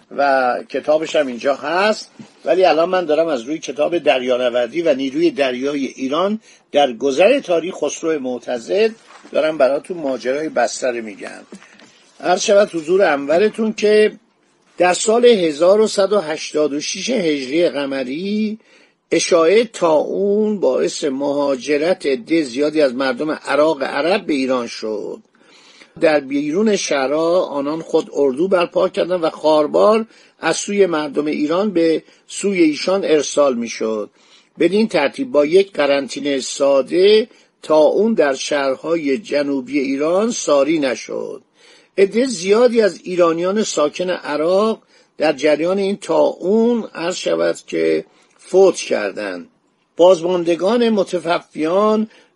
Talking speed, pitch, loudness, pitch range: 120 wpm, 175 Hz, -17 LUFS, 145-215 Hz